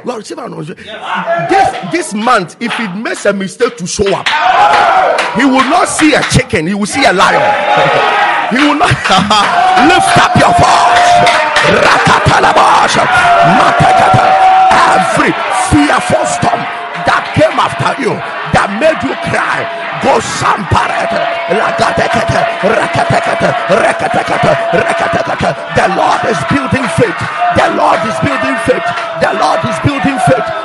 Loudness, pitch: -9 LUFS, 275 Hz